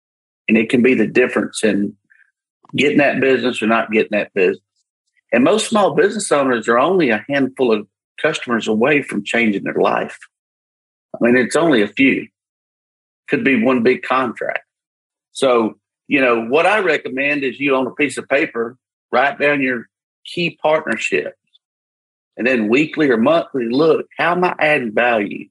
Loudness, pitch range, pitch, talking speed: -16 LUFS, 110-145 Hz, 130 Hz, 165 wpm